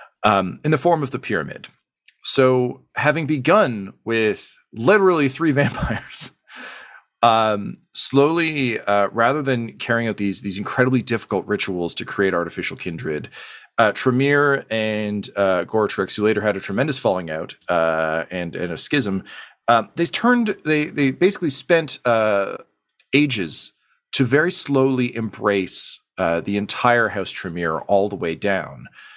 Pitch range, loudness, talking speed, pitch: 100-145 Hz, -20 LUFS, 140 wpm, 120 Hz